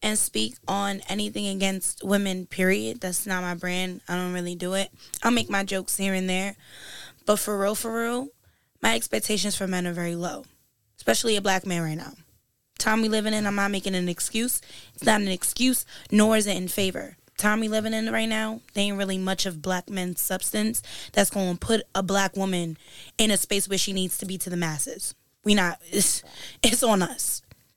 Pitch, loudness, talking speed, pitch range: 195 Hz, -25 LUFS, 210 wpm, 180-210 Hz